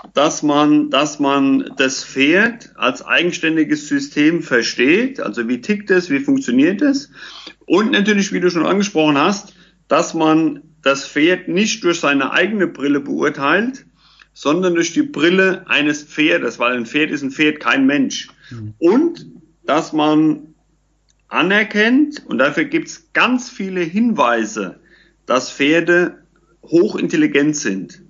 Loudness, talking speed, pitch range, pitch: -16 LUFS, 135 wpm, 150-230 Hz, 170 Hz